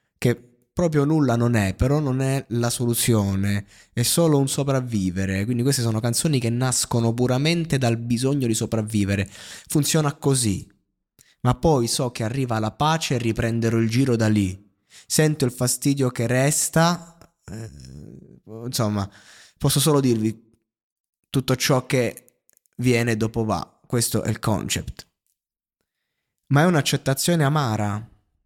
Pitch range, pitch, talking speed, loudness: 110-140 Hz, 120 Hz, 135 wpm, -22 LUFS